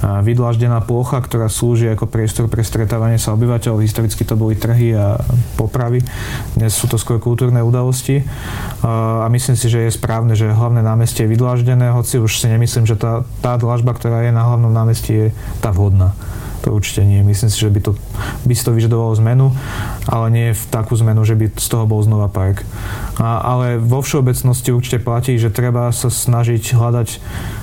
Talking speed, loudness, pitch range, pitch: 185 wpm, -15 LUFS, 110-120 Hz, 115 Hz